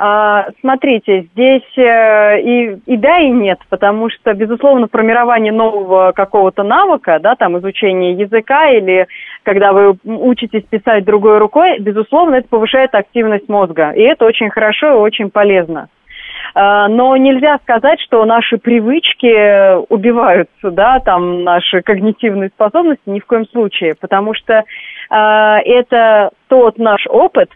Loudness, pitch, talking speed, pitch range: -10 LUFS, 220 Hz, 130 wpm, 200-240 Hz